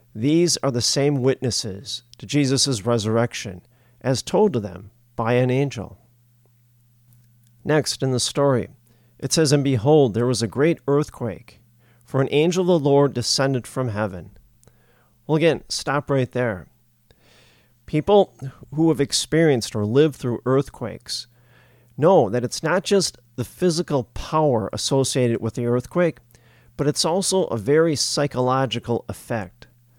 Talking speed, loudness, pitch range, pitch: 140 wpm, -21 LUFS, 115-145 Hz, 125 Hz